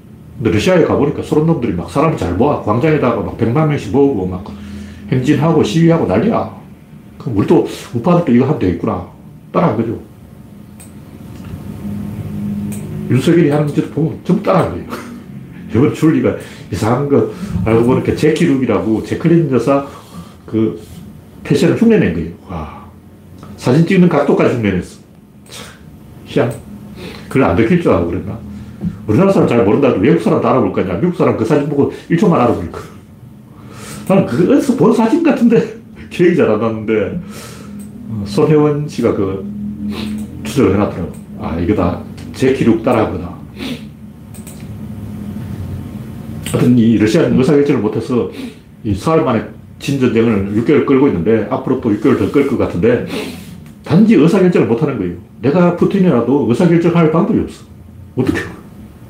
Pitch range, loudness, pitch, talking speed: 105-150 Hz, -14 LUFS, 115 Hz, 315 characters per minute